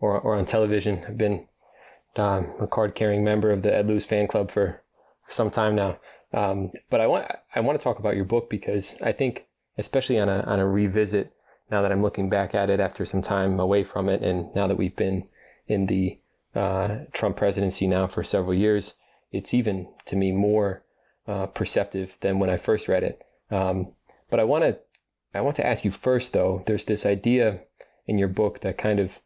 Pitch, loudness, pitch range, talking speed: 100 Hz, -25 LUFS, 95-105 Hz, 205 wpm